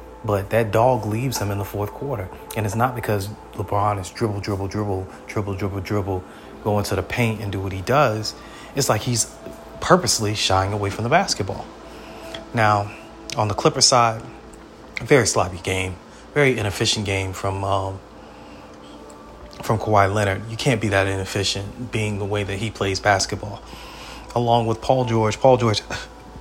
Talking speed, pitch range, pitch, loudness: 170 wpm, 95-115 Hz, 105 Hz, -21 LUFS